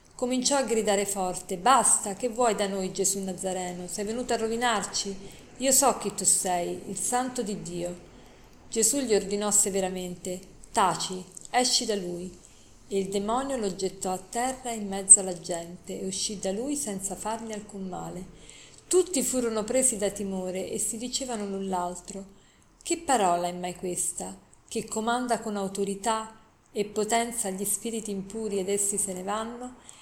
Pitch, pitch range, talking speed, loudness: 200 Hz, 185-230 Hz, 160 wpm, -27 LUFS